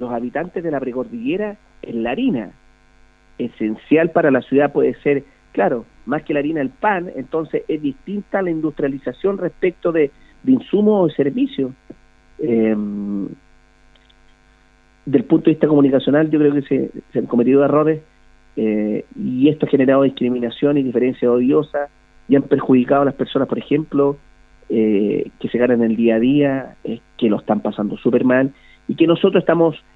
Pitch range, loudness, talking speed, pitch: 115-160 Hz, -18 LUFS, 165 wpm, 135 Hz